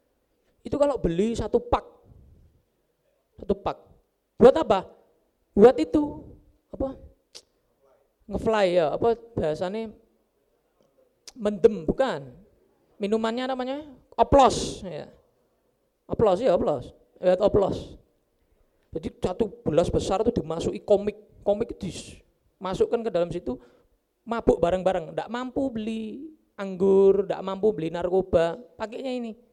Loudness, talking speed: -25 LUFS, 100 wpm